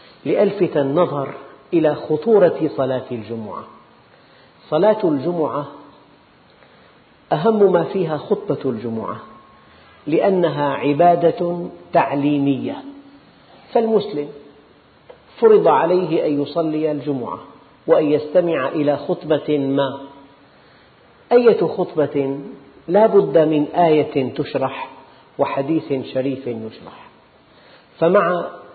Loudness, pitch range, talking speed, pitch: -18 LUFS, 140-180 Hz, 80 wpm, 155 Hz